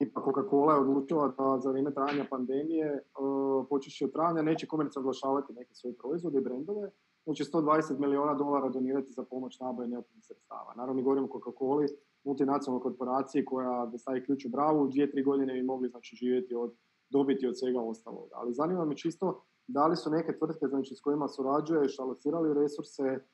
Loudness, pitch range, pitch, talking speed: -32 LUFS, 130-145 Hz, 135 Hz, 190 wpm